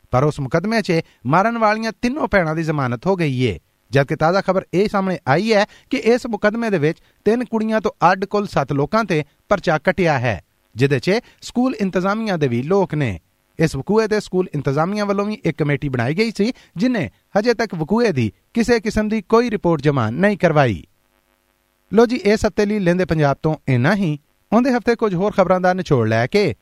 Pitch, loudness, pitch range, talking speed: 185 Hz, -18 LUFS, 145-215 Hz, 200 wpm